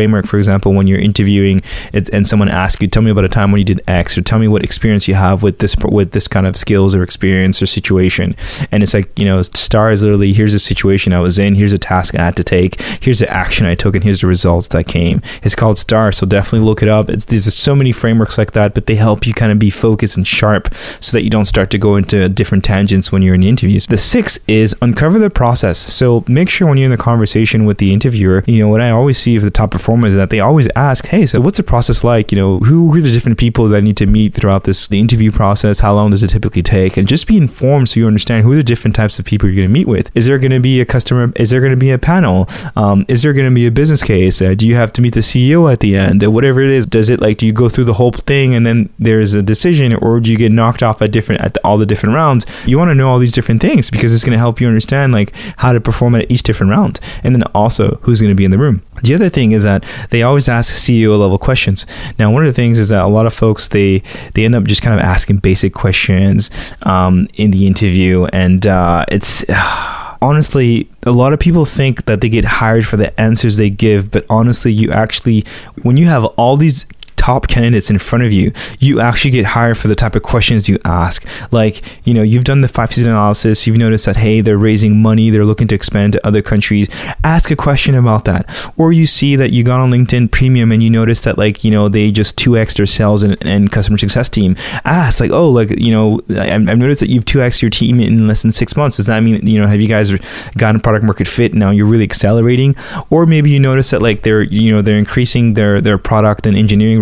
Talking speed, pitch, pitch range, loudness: 265 wpm, 110 Hz, 100-120 Hz, -11 LUFS